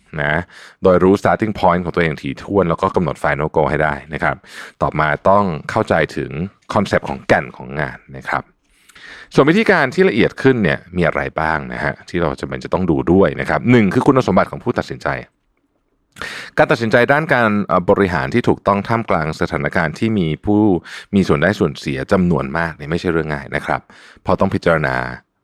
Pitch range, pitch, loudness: 75-105 Hz, 85 Hz, -17 LUFS